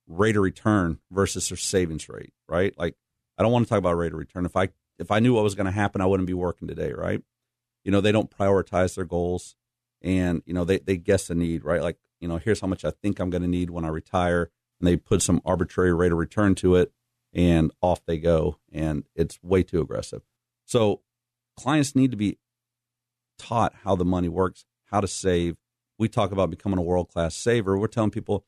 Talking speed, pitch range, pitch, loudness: 230 wpm, 85-110 Hz, 95 Hz, -25 LUFS